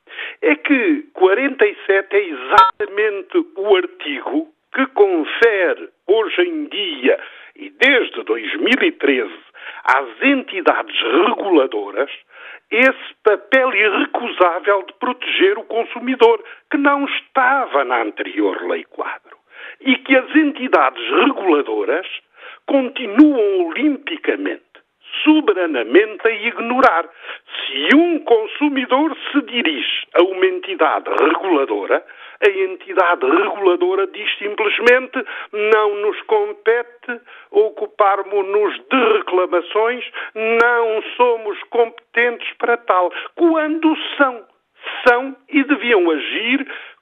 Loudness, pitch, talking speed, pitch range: -16 LUFS, 300 Hz, 95 wpm, 240-395 Hz